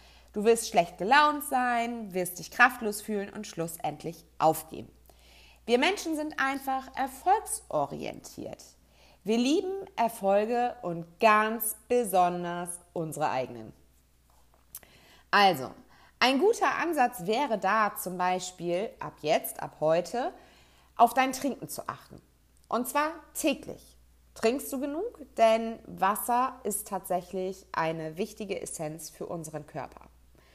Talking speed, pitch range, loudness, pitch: 115 wpm, 170-250 Hz, -29 LUFS, 210 Hz